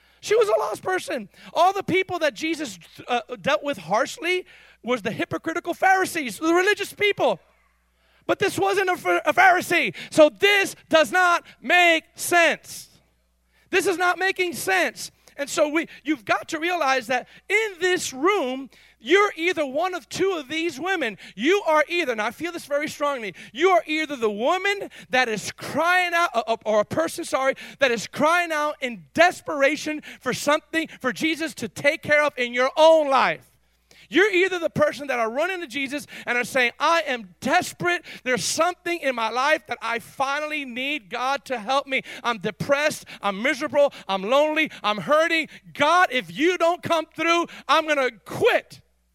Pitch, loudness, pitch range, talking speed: 300 Hz, -22 LUFS, 250-345 Hz, 175 wpm